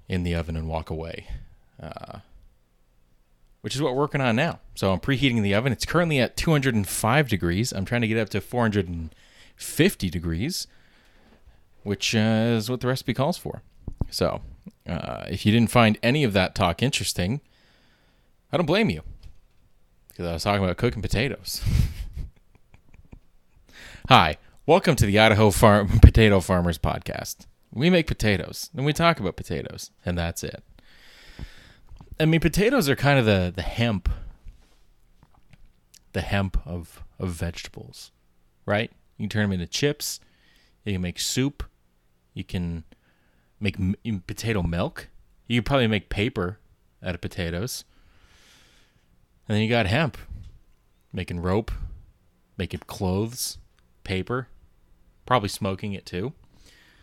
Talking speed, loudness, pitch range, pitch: 140 wpm, -24 LUFS, 85-115 Hz, 100 Hz